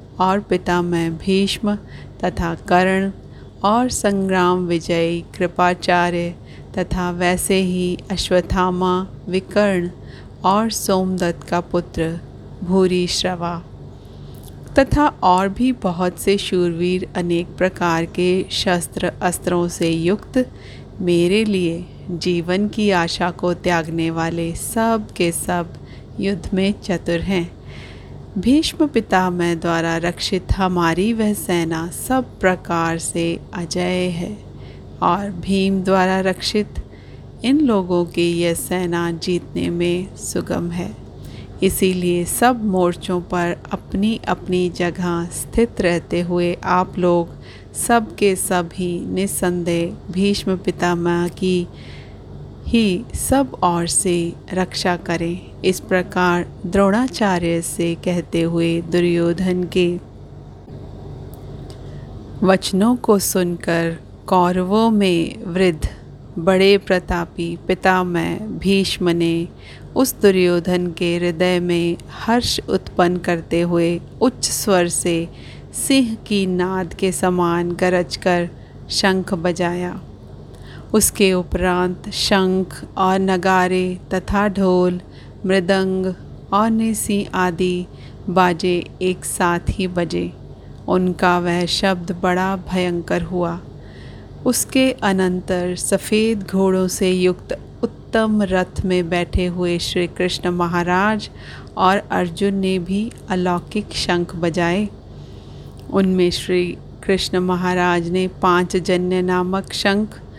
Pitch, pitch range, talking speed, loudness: 180 Hz, 175-190 Hz, 105 wpm, -19 LUFS